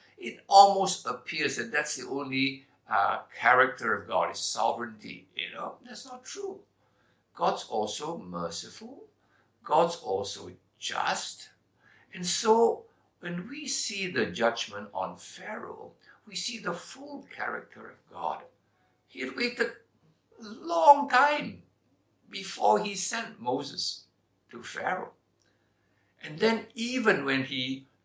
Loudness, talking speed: -28 LUFS, 120 wpm